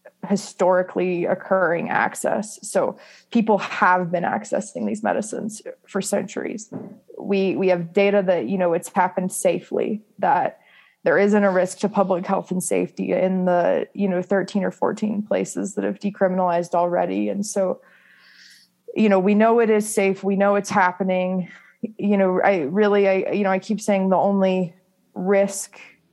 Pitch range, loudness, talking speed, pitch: 185-205 Hz, -21 LUFS, 160 wpm, 195 Hz